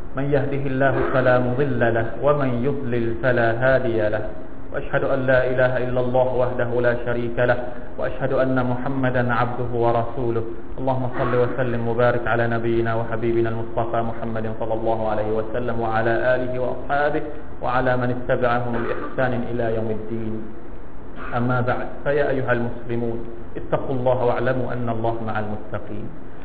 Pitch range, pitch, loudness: 115-125 Hz, 120 Hz, -22 LUFS